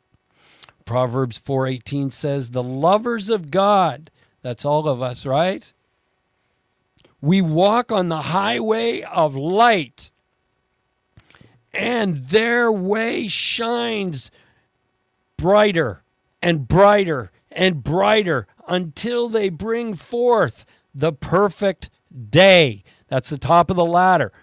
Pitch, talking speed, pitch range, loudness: 165 Hz, 100 wpm, 130-205 Hz, -19 LUFS